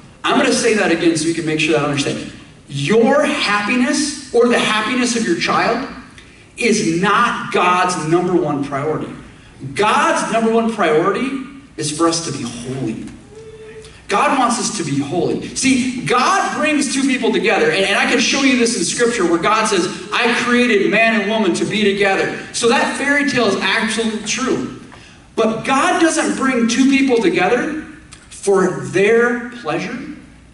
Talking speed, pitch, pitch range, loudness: 170 wpm, 225 Hz, 180-260 Hz, -16 LUFS